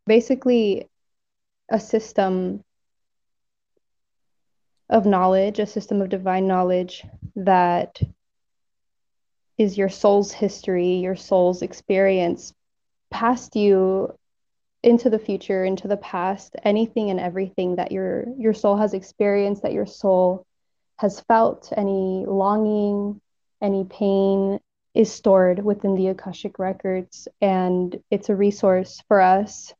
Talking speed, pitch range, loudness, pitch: 115 wpm, 185-210 Hz, -21 LUFS, 195 Hz